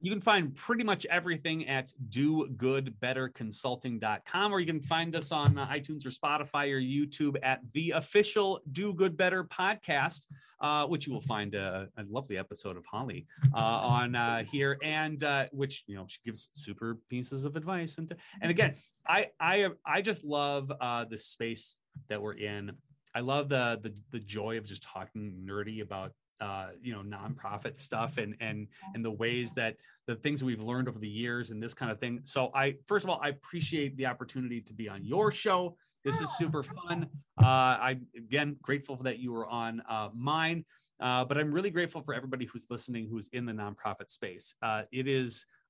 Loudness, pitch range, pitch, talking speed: -33 LUFS, 115-150 Hz, 130 Hz, 195 wpm